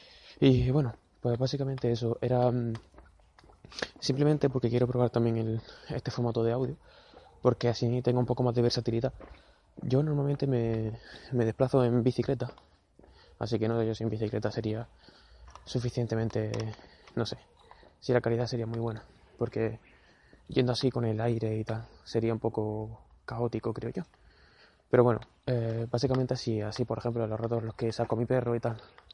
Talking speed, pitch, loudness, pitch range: 170 wpm, 120 Hz, -30 LUFS, 115-125 Hz